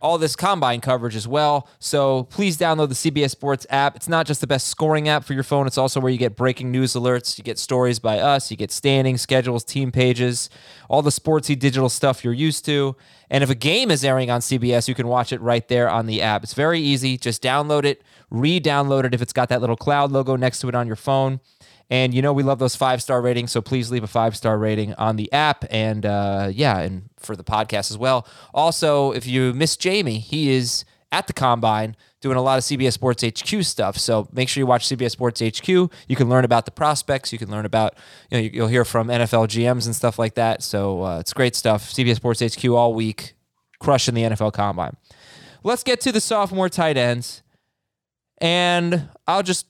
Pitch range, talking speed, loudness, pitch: 115-140 Hz, 225 wpm, -20 LUFS, 130 Hz